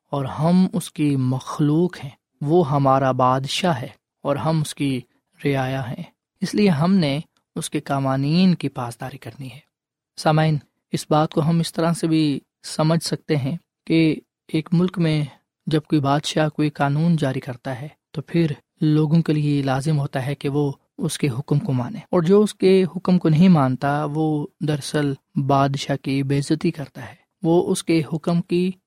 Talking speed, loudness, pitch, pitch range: 180 wpm, -21 LUFS, 155 Hz, 140-165 Hz